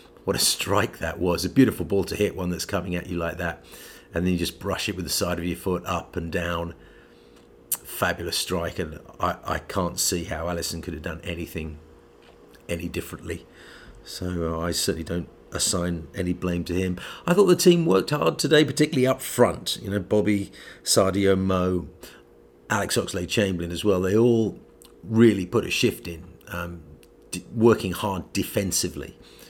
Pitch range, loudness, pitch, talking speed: 85-100 Hz, -24 LUFS, 90 Hz, 175 wpm